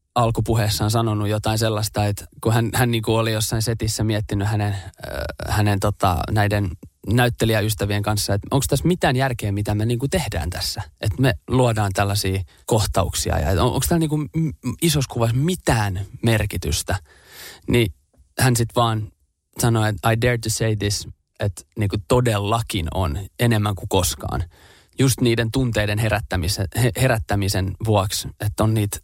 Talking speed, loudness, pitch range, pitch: 150 wpm, -21 LUFS, 100-120 Hz, 110 Hz